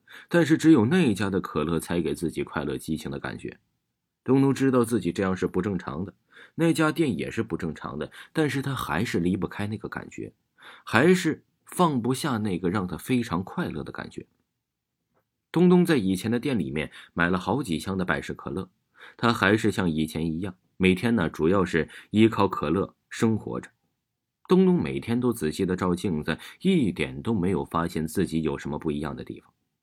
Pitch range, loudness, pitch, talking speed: 80-125 Hz, -25 LUFS, 95 Hz, 280 characters per minute